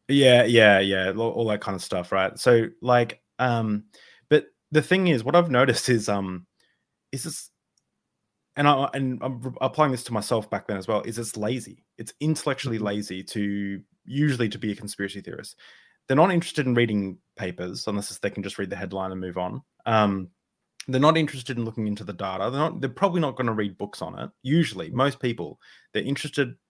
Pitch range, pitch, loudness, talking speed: 100-140 Hz, 115 Hz, -24 LUFS, 200 wpm